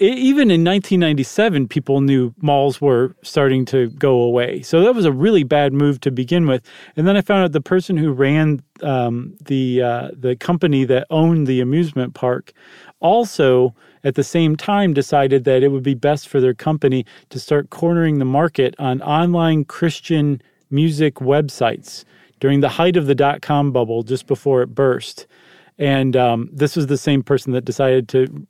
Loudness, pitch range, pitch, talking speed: -17 LUFS, 130-165 Hz, 140 Hz, 180 wpm